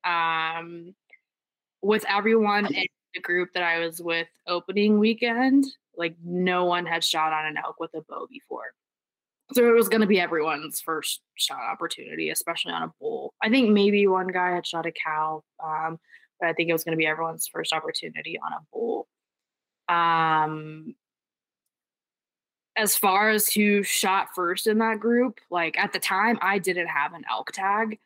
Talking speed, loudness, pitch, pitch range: 175 wpm, -24 LUFS, 180 Hz, 165-215 Hz